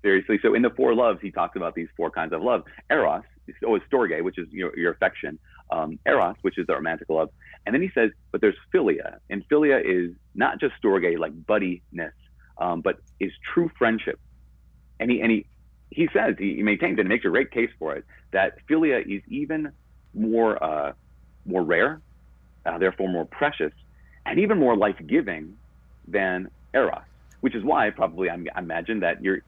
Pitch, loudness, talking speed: 85 Hz, -24 LUFS, 195 wpm